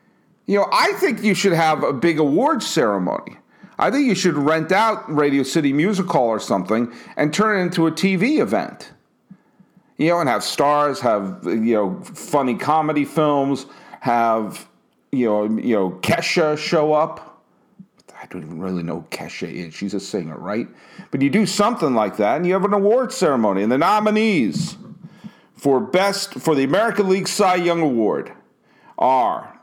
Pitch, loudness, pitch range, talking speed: 160 Hz, -19 LUFS, 140-195 Hz, 170 wpm